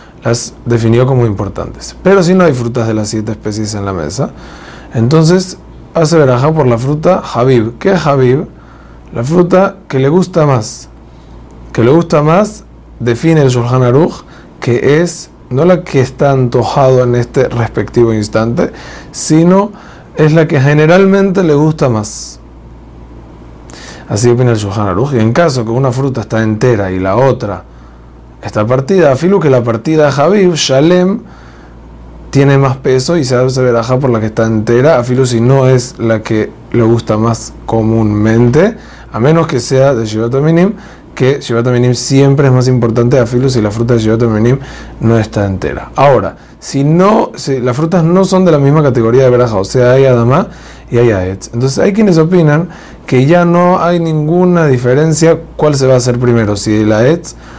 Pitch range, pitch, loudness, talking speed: 115-155 Hz, 125 Hz, -10 LUFS, 175 wpm